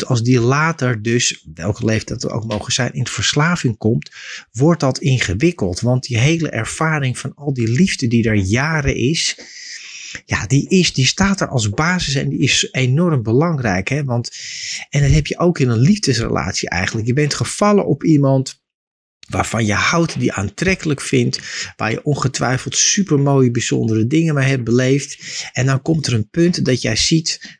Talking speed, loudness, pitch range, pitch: 180 wpm, -17 LUFS, 115-150 Hz, 130 Hz